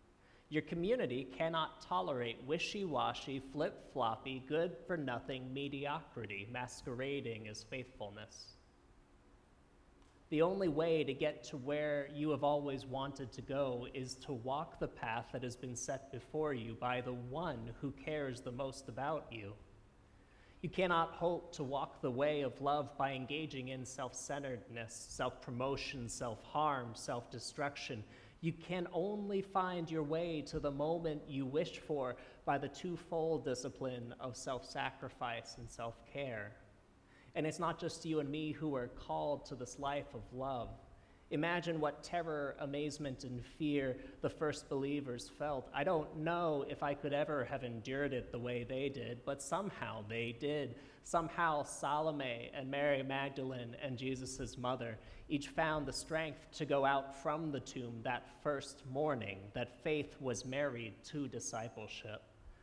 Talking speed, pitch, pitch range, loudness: 155 wpm, 135 Hz, 120-150 Hz, -41 LUFS